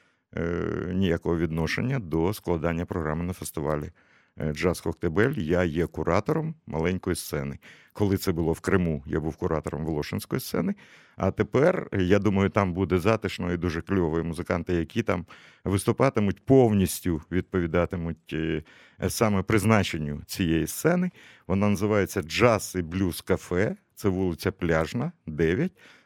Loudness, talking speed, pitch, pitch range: -26 LUFS, 125 wpm, 90 Hz, 85-100 Hz